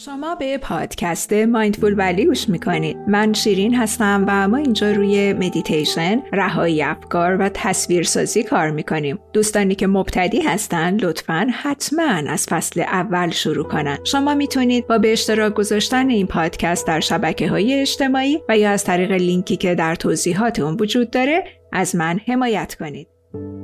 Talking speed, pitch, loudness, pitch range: 150 wpm, 205 Hz, -18 LUFS, 175-230 Hz